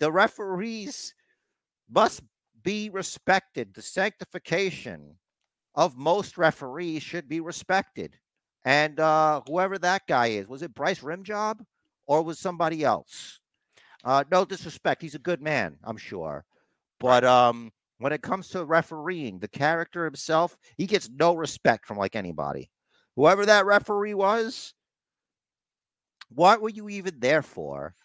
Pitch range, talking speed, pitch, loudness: 140-190 Hz, 135 wpm, 165 Hz, -25 LUFS